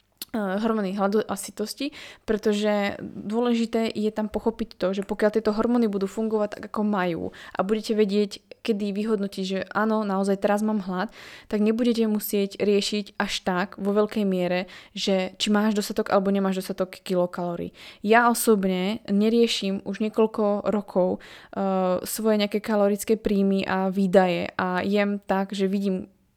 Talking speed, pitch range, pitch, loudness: 150 wpm, 195-220 Hz, 205 Hz, -25 LUFS